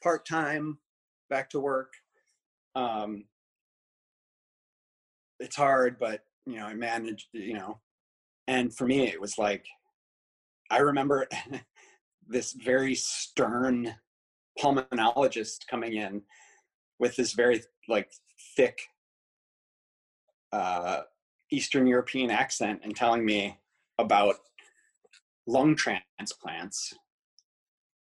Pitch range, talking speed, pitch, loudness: 105-145 Hz, 90 wpm, 125 Hz, -29 LUFS